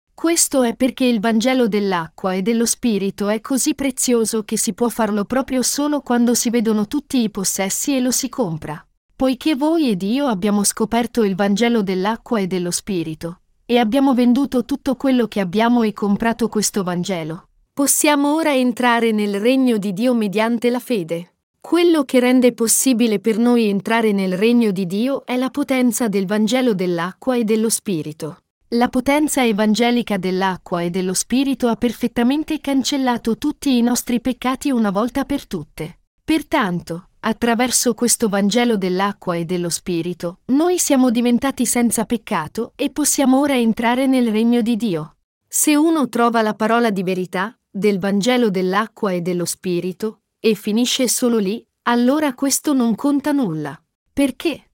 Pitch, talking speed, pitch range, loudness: 235 Hz, 155 wpm, 205-255 Hz, -18 LUFS